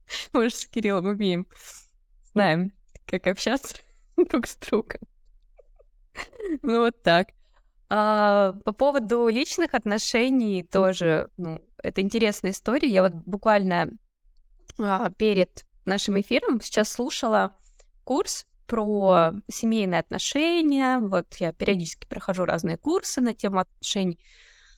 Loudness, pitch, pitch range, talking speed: -24 LUFS, 210 Hz, 190-245 Hz, 110 wpm